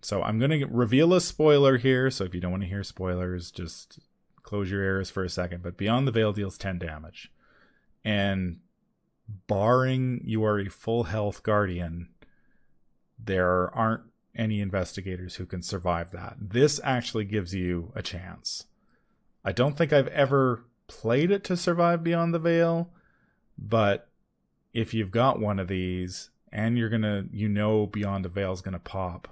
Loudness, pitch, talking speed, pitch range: -27 LUFS, 105 Hz, 170 wpm, 95-125 Hz